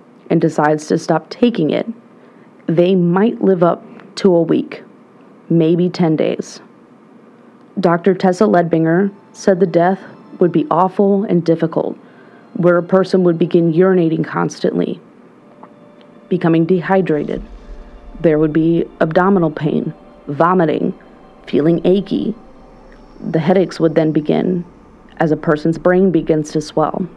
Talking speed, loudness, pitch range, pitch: 125 wpm, -15 LUFS, 165-205 Hz, 180 Hz